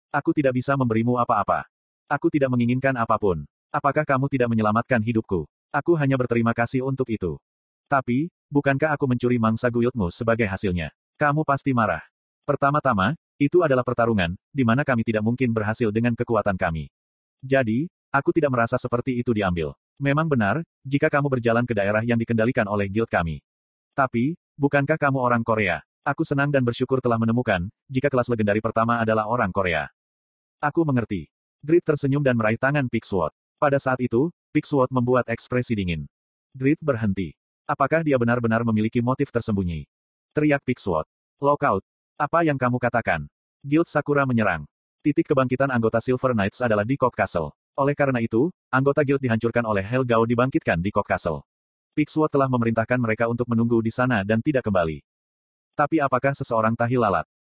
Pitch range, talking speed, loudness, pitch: 110-140 Hz, 155 wpm, -23 LUFS, 120 Hz